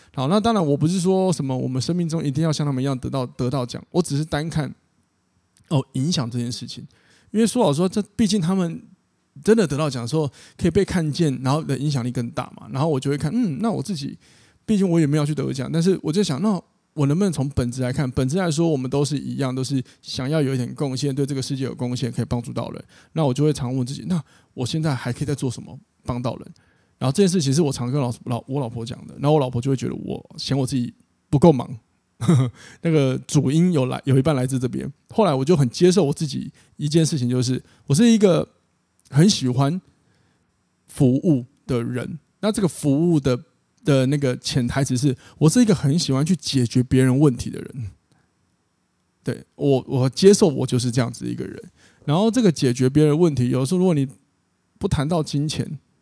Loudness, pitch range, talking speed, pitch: -21 LUFS, 130-165 Hz, 325 characters per minute, 145 Hz